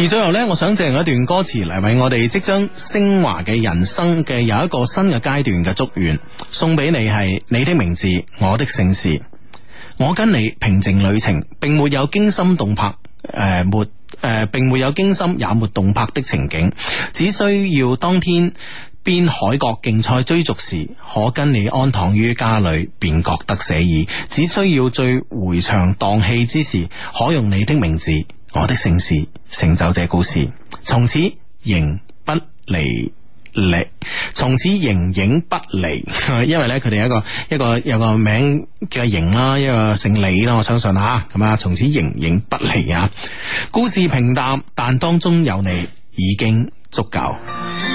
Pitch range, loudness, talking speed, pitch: 100-145 Hz, -17 LUFS, 235 characters per minute, 115 Hz